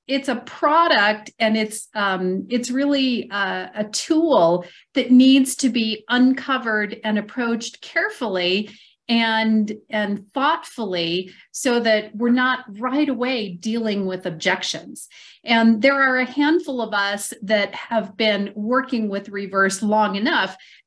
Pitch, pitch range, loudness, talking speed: 225 Hz, 205-255 Hz, -20 LUFS, 130 wpm